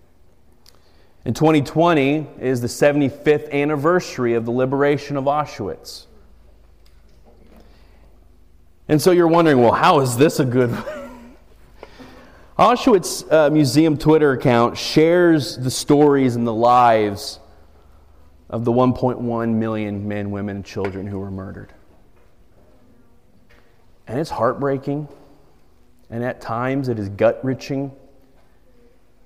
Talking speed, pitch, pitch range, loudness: 110 wpm, 120 Hz, 95-140 Hz, -18 LUFS